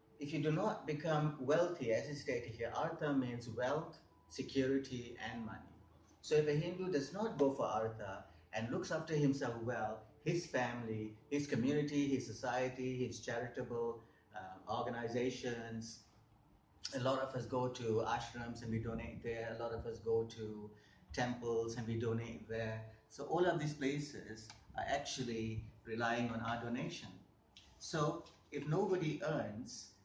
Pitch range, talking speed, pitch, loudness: 110-140 Hz, 155 wpm, 120 Hz, -40 LUFS